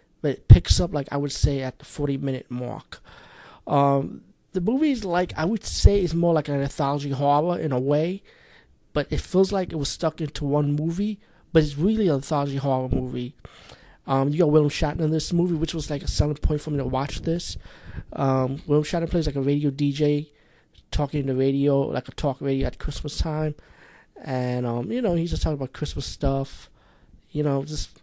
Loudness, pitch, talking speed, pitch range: -24 LUFS, 145 Hz, 210 wpm, 135-160 Hz